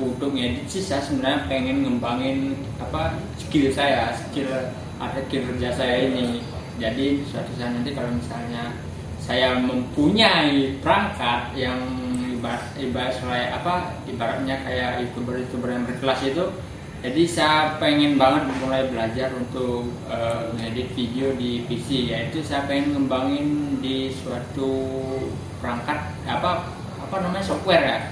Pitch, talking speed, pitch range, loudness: 130 Hz, 130 wpm, 120-135 Hz, -24 LUFS